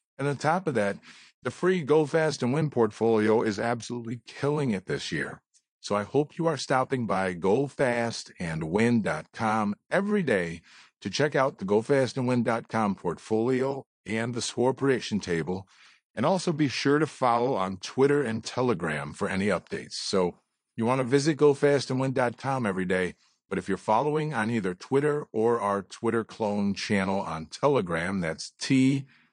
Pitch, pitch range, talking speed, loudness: 120 Hz, 105-140 Hz, 155 wpm, -27 LUFS